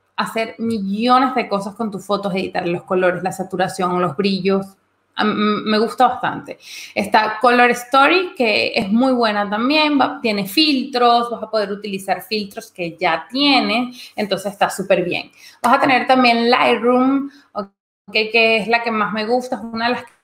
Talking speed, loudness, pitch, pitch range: 170 wpm, -17 LUFS, 225 Hz, 200-245 Hz